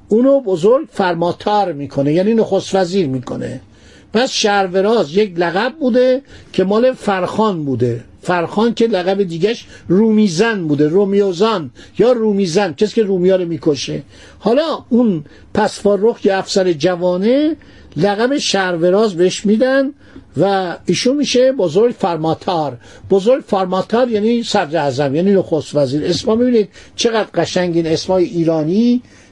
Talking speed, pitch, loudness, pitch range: 125 wpm, 195 Hz, -15 LUFS, 170-225 Hz